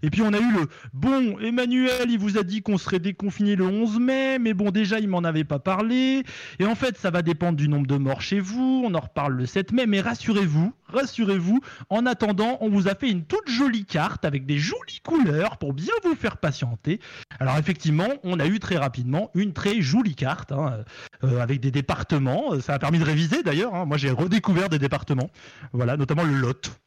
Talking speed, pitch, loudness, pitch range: 220 wpm, 185 Hz, -24 LUFS, 145-220 Hz